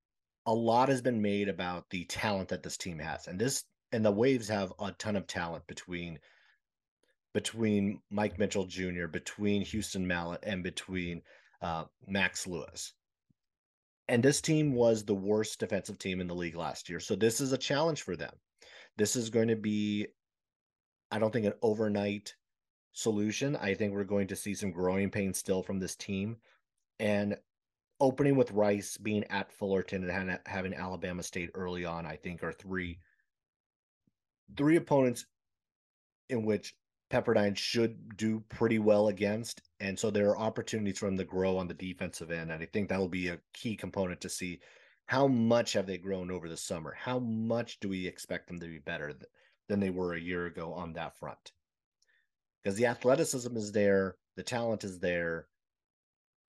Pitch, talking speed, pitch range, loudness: 100 Hz, 175 wpm, 90-110 Hz, -33 LUFS